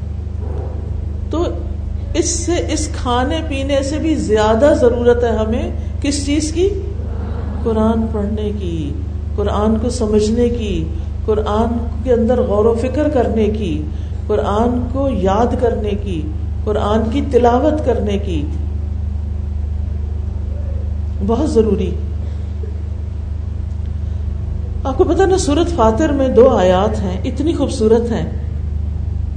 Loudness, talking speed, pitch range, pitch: -17 LUFS, 110 wpm, 80-95 Hz, 85 Hz